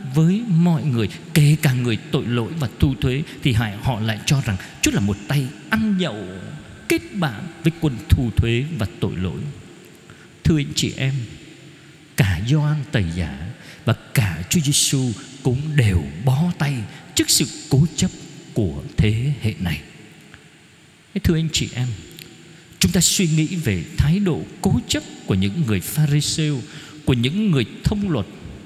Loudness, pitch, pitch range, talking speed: -21 LUFS, 140 Hz, 110-160 Hz, 165 wpm